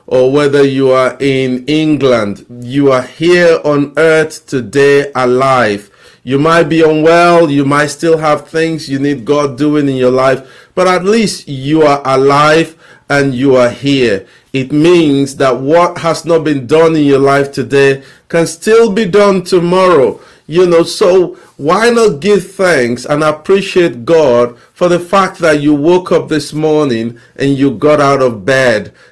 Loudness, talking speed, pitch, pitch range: -10 LUFS, 165 wpm, 150 Hz, 135-170 Hz